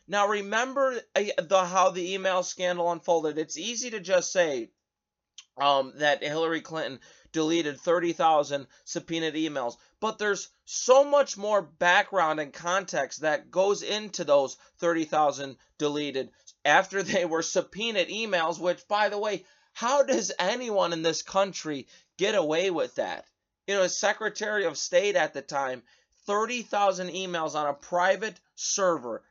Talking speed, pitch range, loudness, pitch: 140 wpm, 155-205 Hz, -27 LUFS, 180 Hz